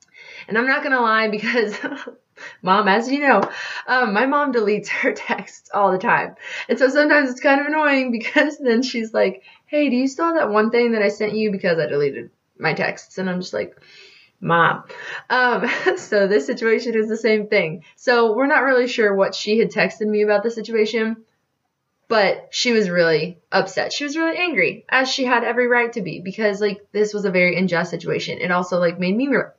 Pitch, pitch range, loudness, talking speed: 225 Hz, 205-260 Hz, -19 LUFS, 205 wpm